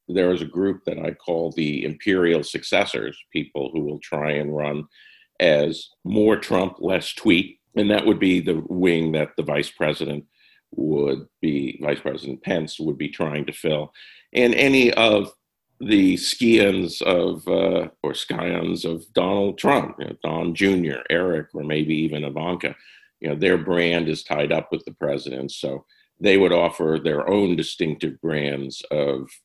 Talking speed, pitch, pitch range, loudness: 160 wpm, 85 Hz, 75-95 Hz, -22 LUFS